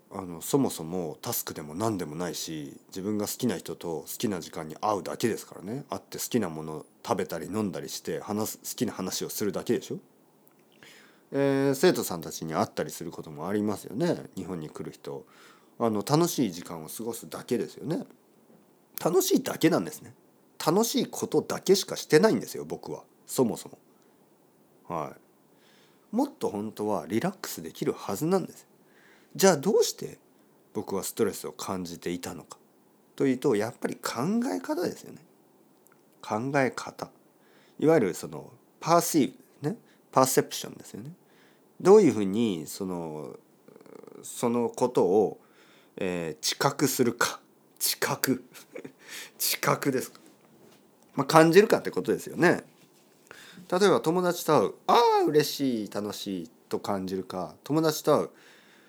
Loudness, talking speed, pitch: -28 LUFS, 310 characters per minute, 125 Hz